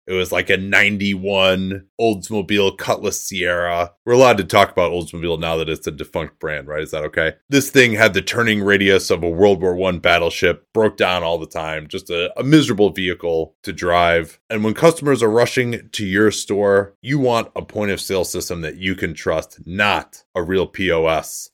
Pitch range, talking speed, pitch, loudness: 85-110 Hz, 200 wpm, 95 Hz, -18 LUFS